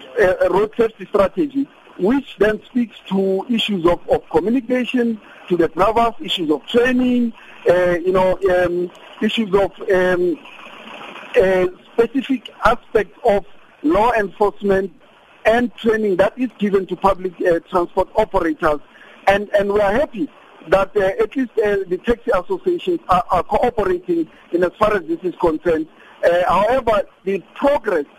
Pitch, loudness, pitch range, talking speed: 205 Hz, -18 LUFS, 185-250 Hz, 145 wpm